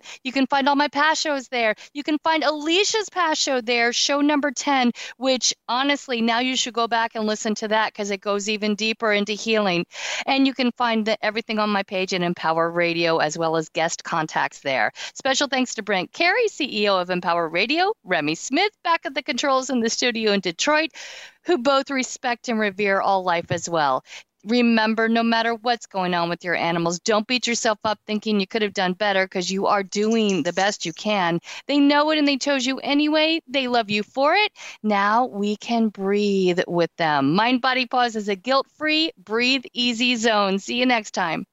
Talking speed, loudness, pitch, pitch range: 205 wpm, -21 LUFS, 230 Hz, 200-270 Hz